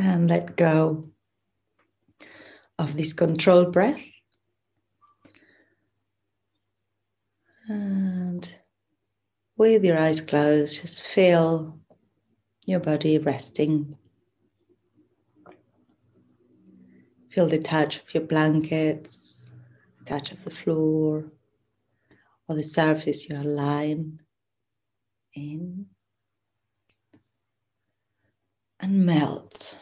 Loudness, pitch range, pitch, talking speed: -23 LUFS, 105-160 Hz, 145 Hz, 70 wpm